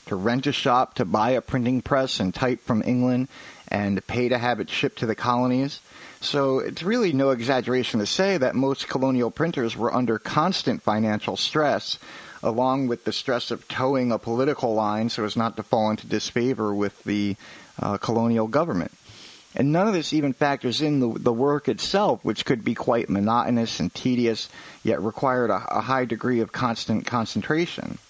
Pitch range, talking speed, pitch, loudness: 110-130 Hz, 185 wpm, 120 Hz, -24 LUFS